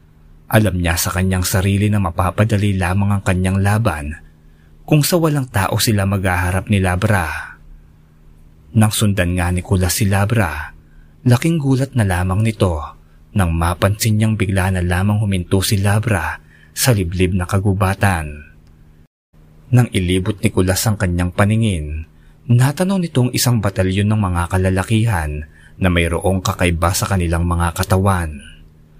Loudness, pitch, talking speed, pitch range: -17 LUFS, 95 Hz, 135 wpm, 80-105 Hz